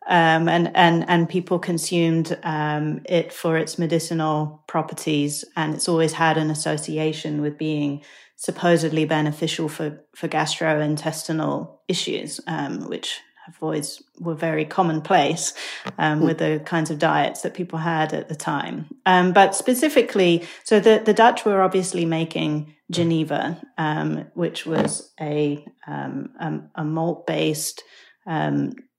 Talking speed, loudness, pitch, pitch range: 135 wpm, -22 LUFS, 160 Hz, 155-170 Hz